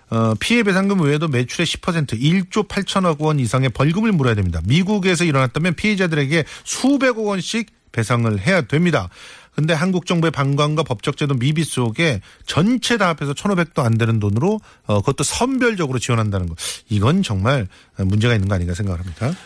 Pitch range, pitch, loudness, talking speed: 115-185 Hz, 150 Hz, -19 LUFS, 375 characters per minute